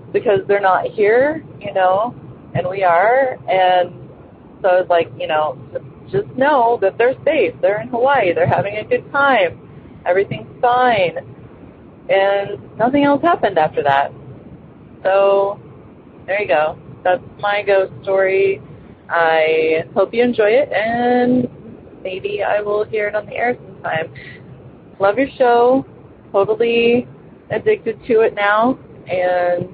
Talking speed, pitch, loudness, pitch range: 135 wpm, 205 Hz, -16 LUFS, 180-245 Hz